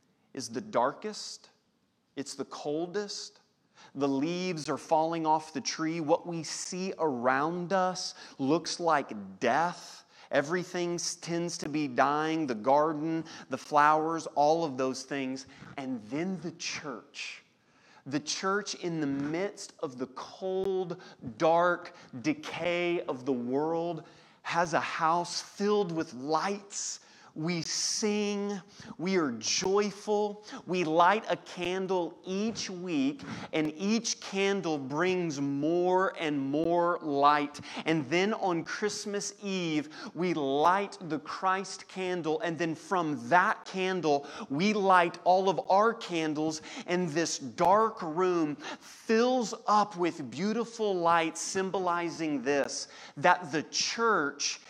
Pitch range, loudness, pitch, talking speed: 155-190 Hz, -30 LUFS, 175 Hz, 120 wpm